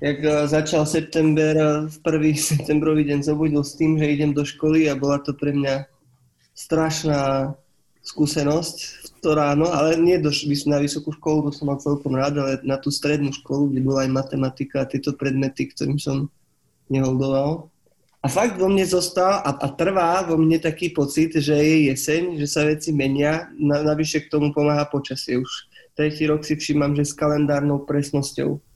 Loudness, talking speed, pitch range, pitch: -21 LUFS, 175 wpm, 140-155 Hz, 150 Hz